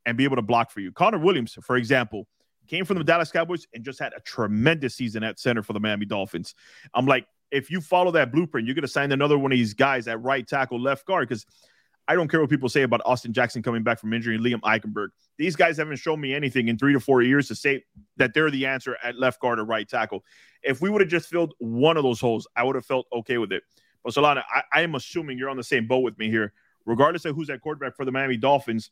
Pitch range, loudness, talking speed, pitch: 115-145 Hz, -24 LUFS, 265 wpm, 130 Hz